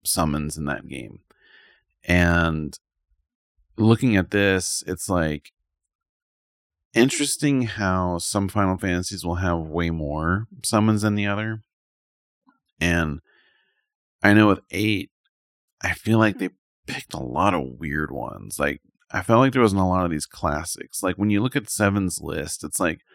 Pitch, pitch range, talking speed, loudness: 90 Hz, 80-105 Hz, 150 wpm, -23 LUFS